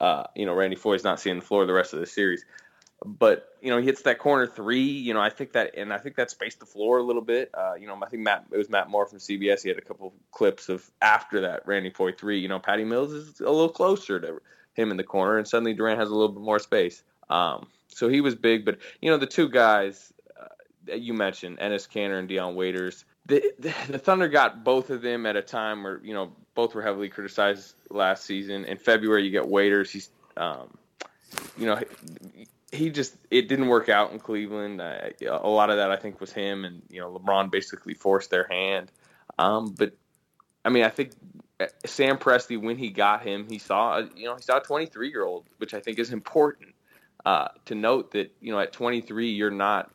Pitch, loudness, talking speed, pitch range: 110 Hz, -26 LUFS, 235 wpm, 100-125 Hz